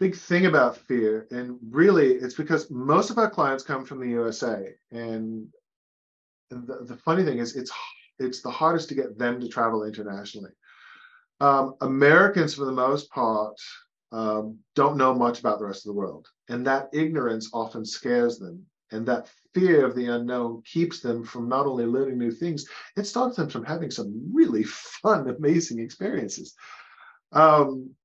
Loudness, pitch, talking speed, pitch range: -24 LUFS, 130 Hz, 170 wpm, 115-155 Hz